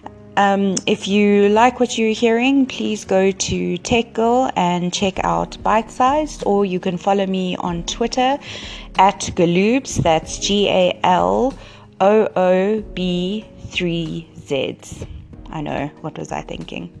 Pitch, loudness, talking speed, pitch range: 195 Hz, -18 LUFS, 140 wpm, 180-225 Hz